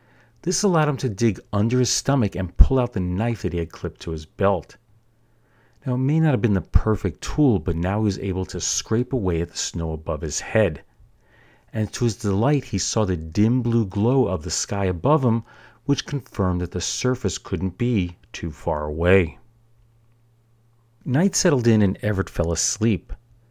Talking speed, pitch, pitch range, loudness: 190 wpm, 110 Hz, 95-120 Hz, -22 LUFS